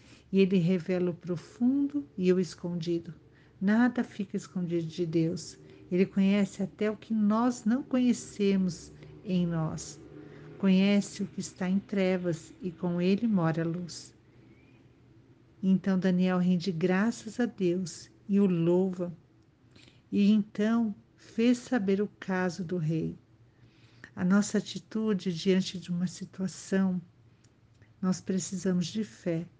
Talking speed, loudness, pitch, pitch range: 125 wpm, -29 LUFS, 185 Hz, 170-200 Hz